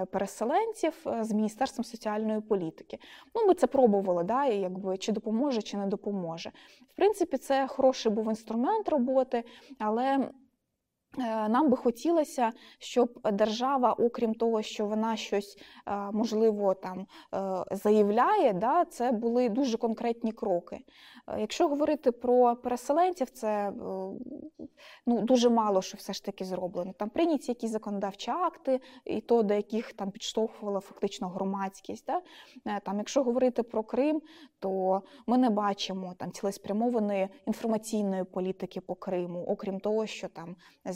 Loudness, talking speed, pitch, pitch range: -30 LUFS, 130 wpm, 225 Hz, 200-255 Hz